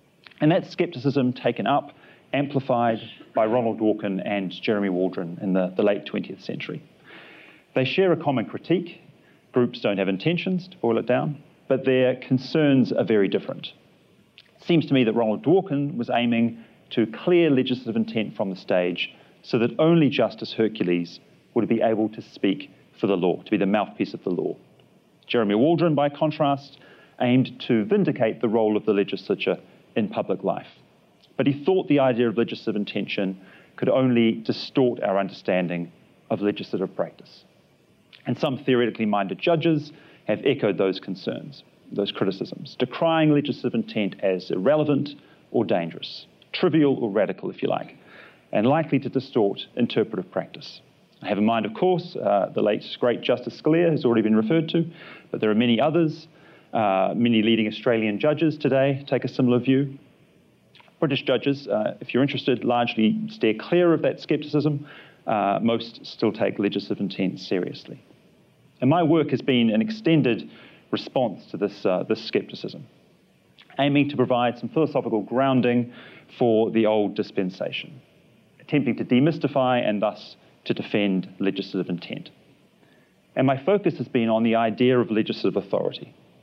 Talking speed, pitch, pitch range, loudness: 160 wpm, 125 Hz, 110-150 Hz, -23 LUFS